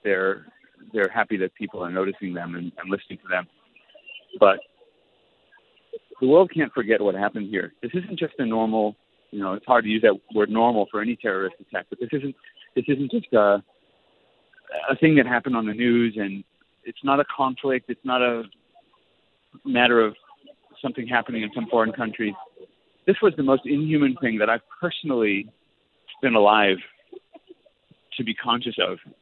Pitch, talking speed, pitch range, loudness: 120 Hz, 175 wpm, 105-160 Hz, -23 LUFS